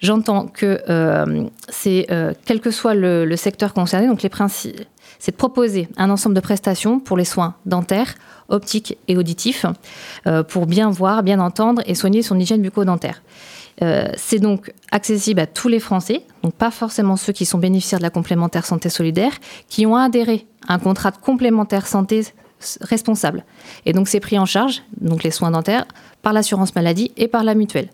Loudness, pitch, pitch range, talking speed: -18 LUFS, 200 Hz, 180-220 Hz, 185 wpm